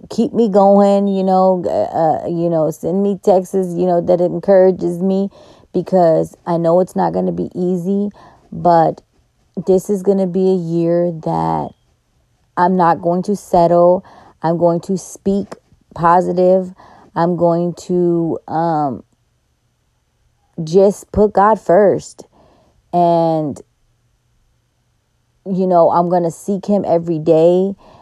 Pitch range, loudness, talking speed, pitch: 165-190 Hz, -15 LUFS, 135 wpm, 175 Hz